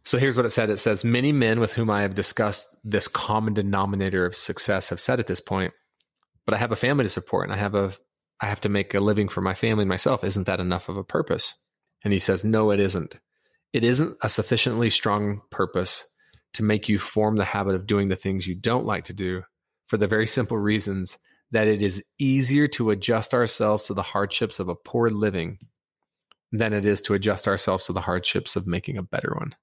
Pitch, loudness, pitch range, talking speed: 105 Hz, -24 LUFS, 100-115 Hz, 225 wpm